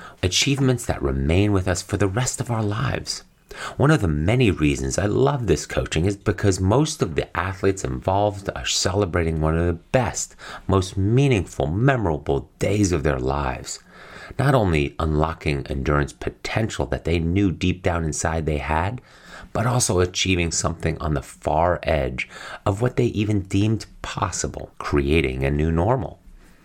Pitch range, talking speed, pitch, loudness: 75-105 Hz, 160 wpm, 90 Hz, -22 LUFS